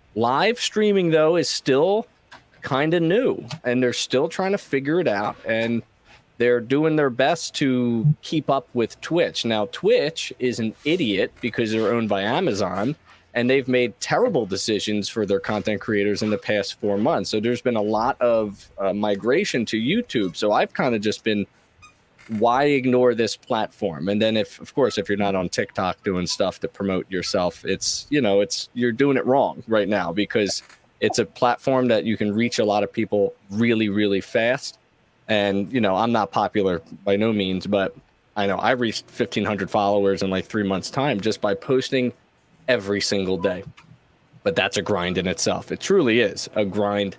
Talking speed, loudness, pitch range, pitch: 190 wpm, -22 LUFS, 100-125 Hz, 110 Hz